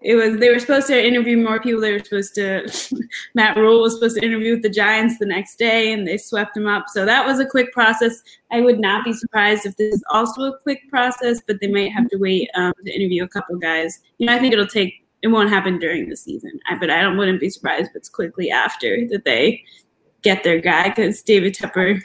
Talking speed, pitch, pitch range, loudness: 250 wpm, 215 Hz, 200-235 Hz, -18 LUFS